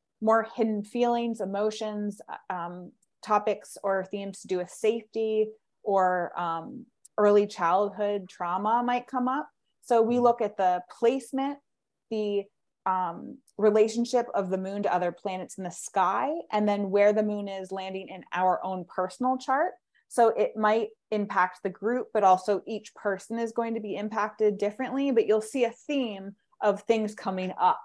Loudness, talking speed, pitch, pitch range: -28 LUFS, 160 wpm, 210 Hz, 195-230 Hz